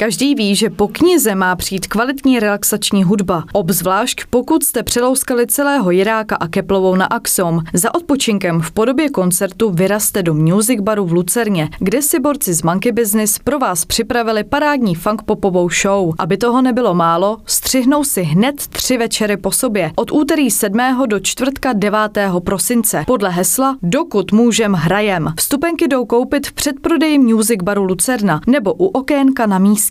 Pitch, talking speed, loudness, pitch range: 215 Hz, 160 wpm, -14 LUFS, 195-255 Hz